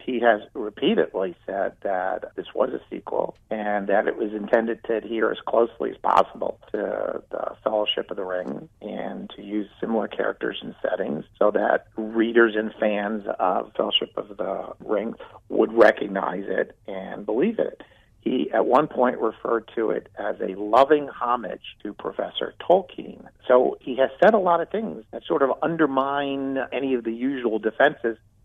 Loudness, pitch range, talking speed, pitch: -24 LUFS, 105-135 Hz, 170 wpm, 115 Hz